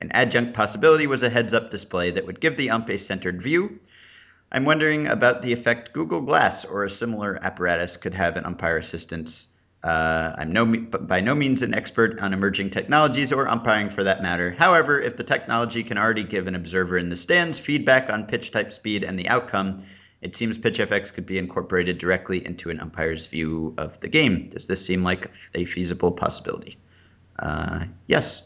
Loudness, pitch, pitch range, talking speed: -23 LUFS, 100 Hz, 90-115 Hz, 190 wpm